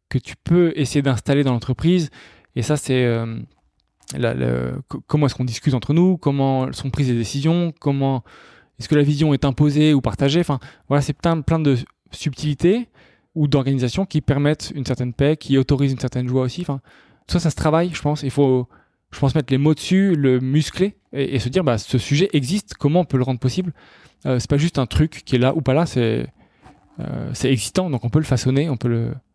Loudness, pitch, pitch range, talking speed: -20 LUFS, 140 Hz, 130-155 Hz, 225 wpm